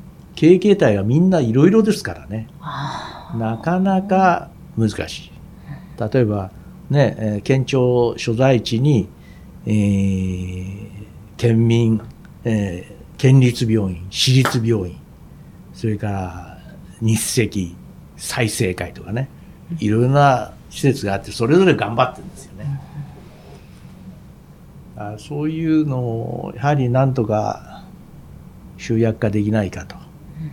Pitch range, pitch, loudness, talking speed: 100-140 Hz, 115 Hz, -18 LUFS, 210 characters per minute